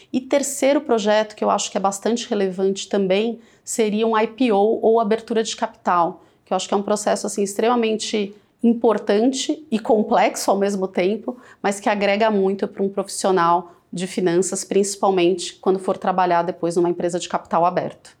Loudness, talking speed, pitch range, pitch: -20 LUFS, 170 wpm, 190-225 Hz, 205 Hz